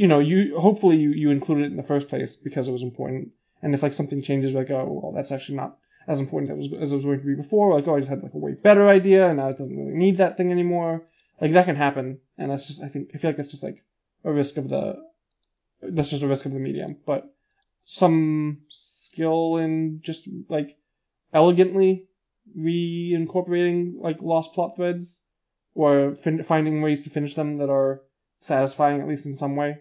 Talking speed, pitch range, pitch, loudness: 225 wpm, 140-175 Hz, 155 Hz, -23 LUFS